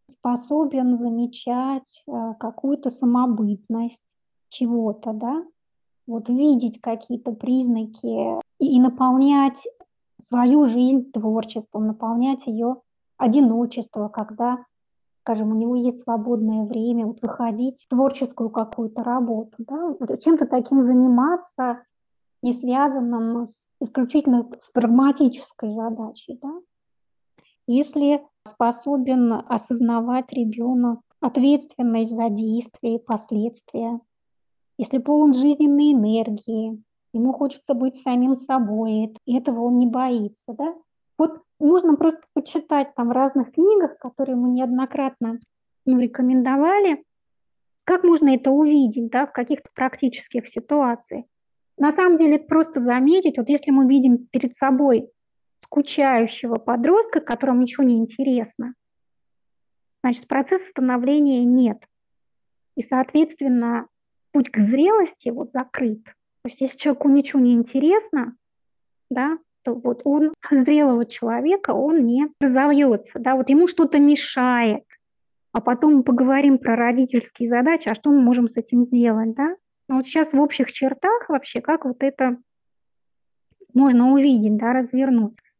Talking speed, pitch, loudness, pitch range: 120 wpm, 255 Hz, -20 LUFS, 235-280 Hz